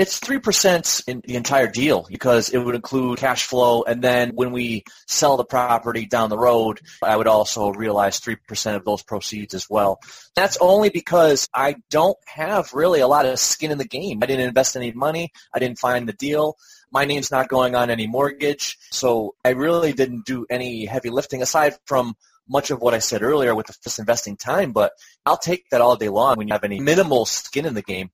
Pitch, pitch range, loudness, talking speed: 125 Hz, 115-140 Hz, -20 LUFS, 210 wpm